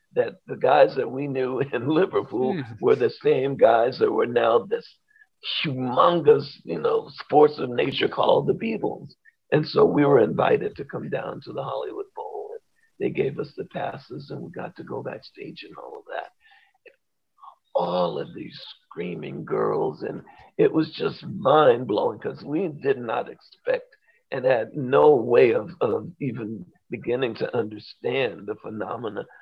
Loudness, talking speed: -23 LUFS, 165 wpm